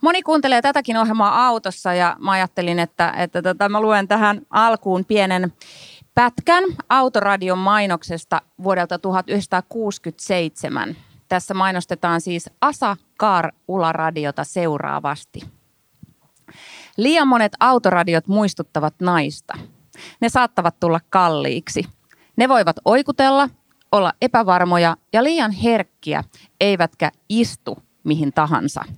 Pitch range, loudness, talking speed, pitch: 170-230 Hz, -18 LUFS, 100 wpm, 190 Hz